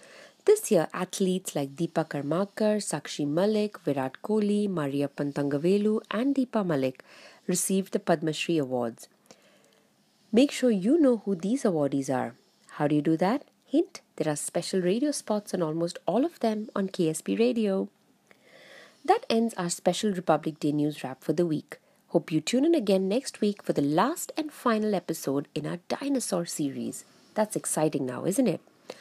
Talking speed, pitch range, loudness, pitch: 165 wpm, 155-220 Hz, -28 LUFS, 185 Hz